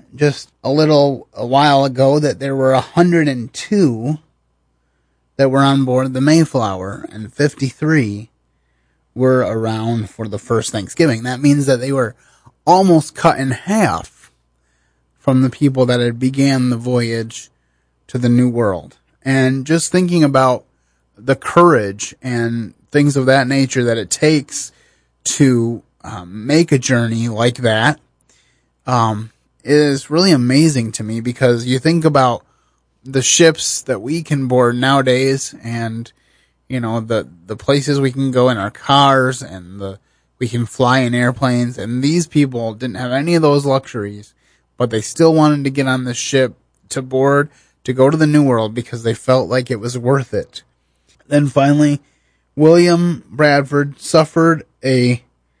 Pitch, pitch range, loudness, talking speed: 130 Hz, 115-140 Hz, -15 LUFS, 155 wpm